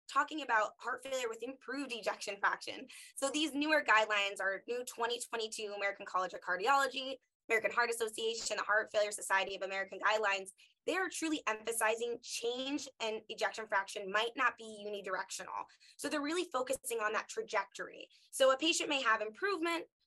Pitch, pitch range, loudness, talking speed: 235 Hz, 210-290 Hz, -35 LUFS, 160 wpm